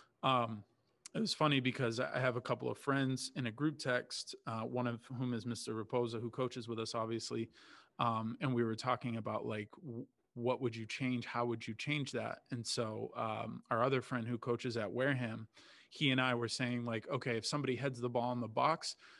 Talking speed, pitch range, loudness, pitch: 215 wpm, 115-130 Hz, -38 LUFS, 120 Hz